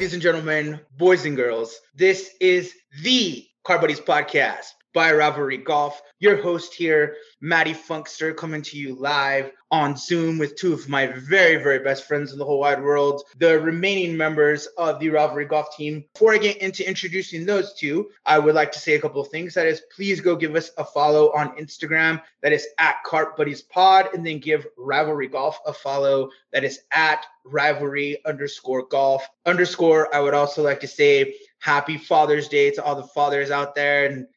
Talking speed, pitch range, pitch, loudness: 190 wpm, 145-170 Hz, 150 Hz, -21 LUFS